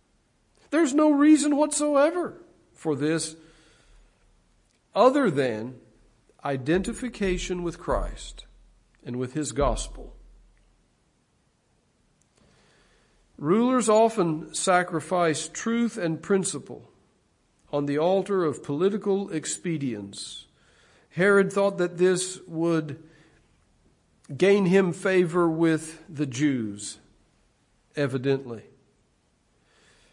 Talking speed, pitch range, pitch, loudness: 80 wpm, 145-195 Hz, 165 Hz, -25 LUFS